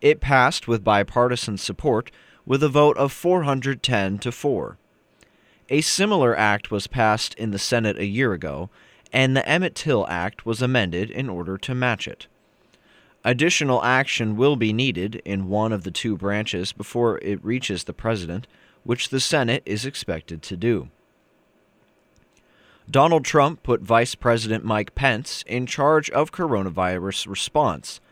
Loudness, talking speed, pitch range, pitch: -22 LUFS, 145 wpm, 100-135 Hz, 115 Hz